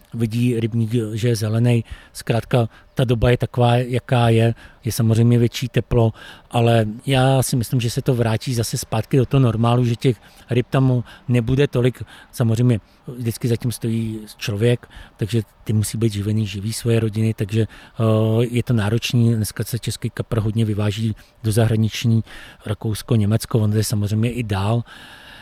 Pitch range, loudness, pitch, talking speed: 110-120 Hz, -20 LUFS, 115 Hz, 160 wpm